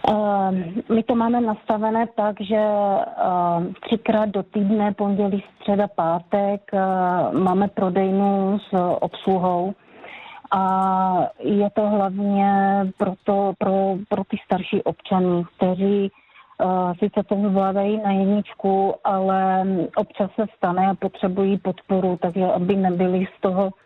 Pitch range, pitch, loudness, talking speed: 190-205 Hz, 195 Hz, -21 LUFS, 110 wpm